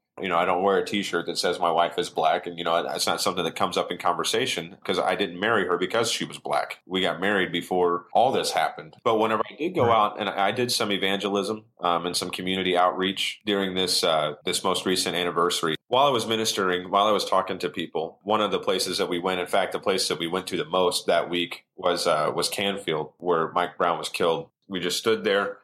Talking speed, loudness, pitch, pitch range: 245 wpm, -25 LUFS, 95 Hz, 90-100 Hz